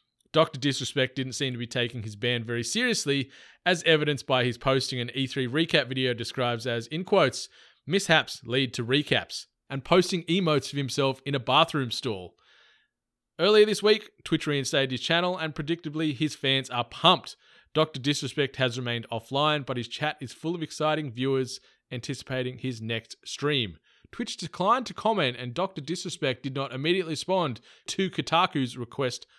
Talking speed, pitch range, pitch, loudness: 165 wpm, 130-160 Hz, 140 Hz, -27 LUFS